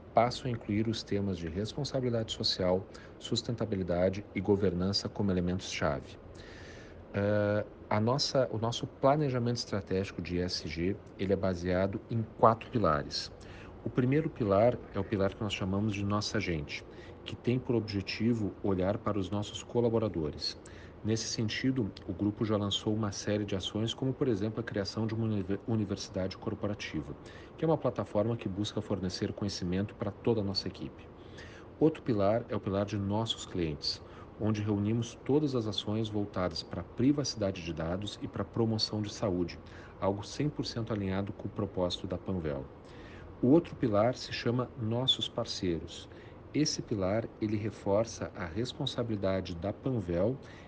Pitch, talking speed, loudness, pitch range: 105 Hz, 150 wpm, -33 LUFS, 95-115 Hz